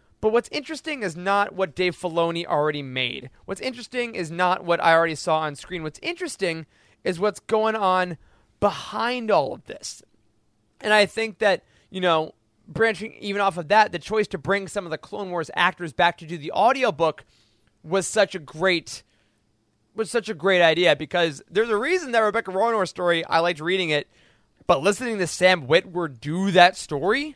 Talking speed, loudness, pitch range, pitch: 185 wpm, -23 LUFS, 165-210 Hz, 185 Hz